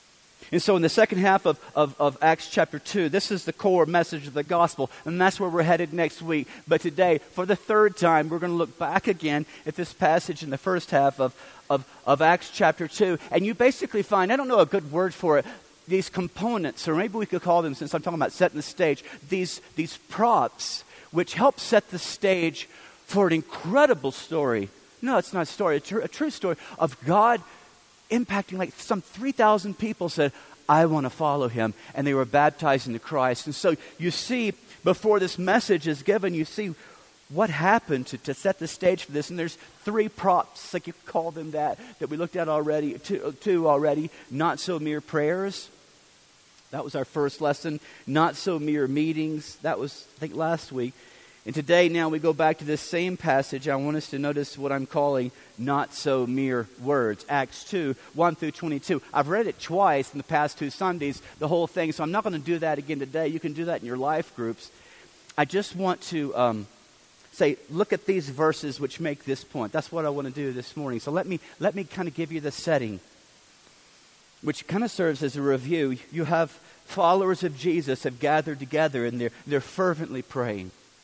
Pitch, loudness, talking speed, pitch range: 160 Hz, -26 LUFS, 215 wpm, 145-180 Hz